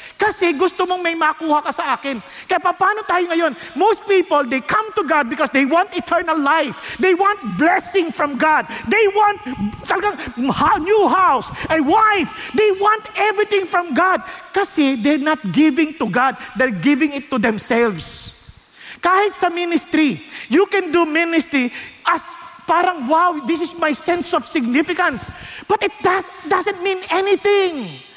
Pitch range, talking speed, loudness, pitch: 295-375 Hz, 155 wpm, -17 LUFS, 340 Hz